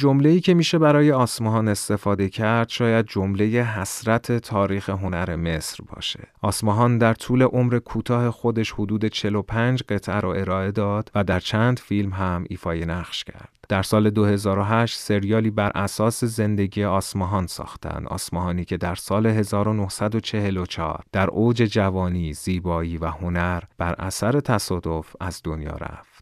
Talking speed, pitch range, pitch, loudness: 135 wpm, 95-115 Hz, 105 Hz, -22 LUFS